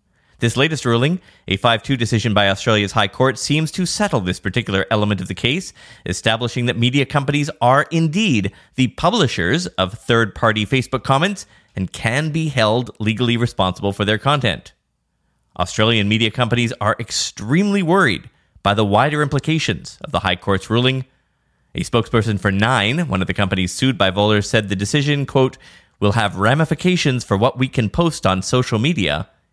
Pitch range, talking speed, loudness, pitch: 100-135 Hz, 165 wpm, -18 LUFS, 115 Hz